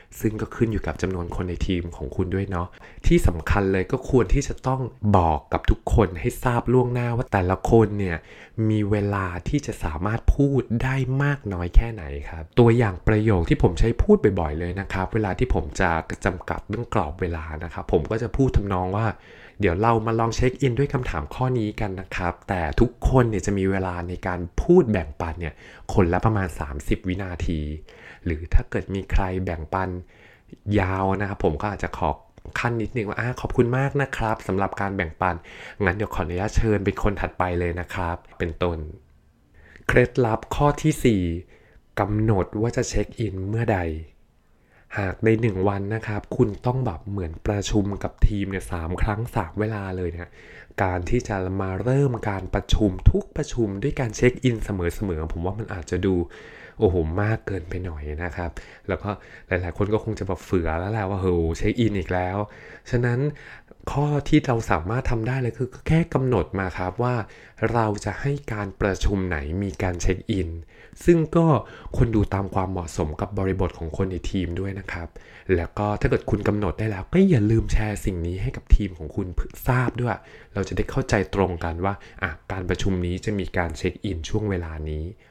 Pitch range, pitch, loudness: 90-115 Hz, 100 Hz, -24 LUFS